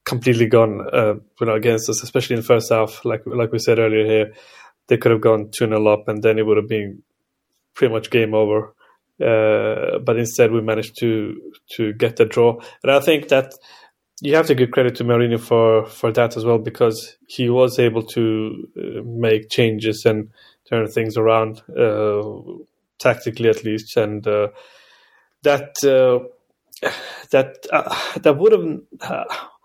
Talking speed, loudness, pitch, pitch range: 170 wpm, -18 LUFS, 115 Hz, 110-120 Hz